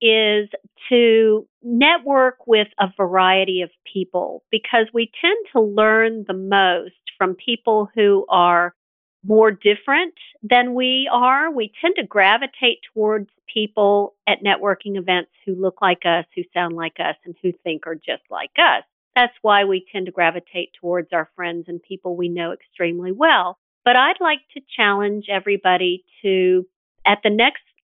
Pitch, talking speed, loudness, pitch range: 200 Hz, 155 wpm, -18 LUFS, 180-230 Hz